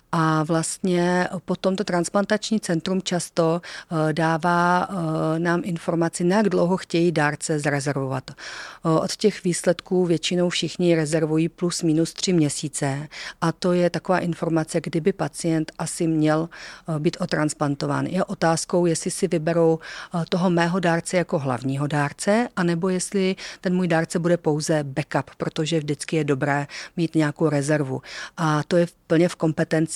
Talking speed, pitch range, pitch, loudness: 135 wpm, 155-180 Hz, 170 Hz, -23 LUFS